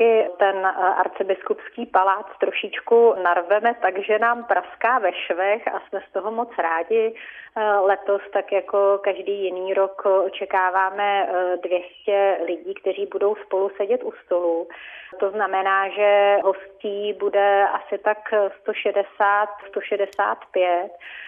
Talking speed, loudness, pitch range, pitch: 110 wpm, -21 LUFS, 190-205 Hz, 200 Hz